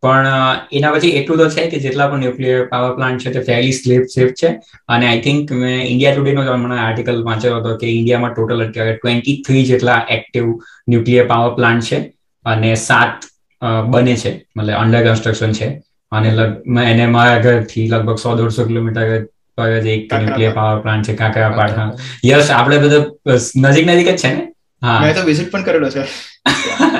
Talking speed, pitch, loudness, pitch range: 180 wpm, 120 Hz, -14 LUFS, 115-135 Hz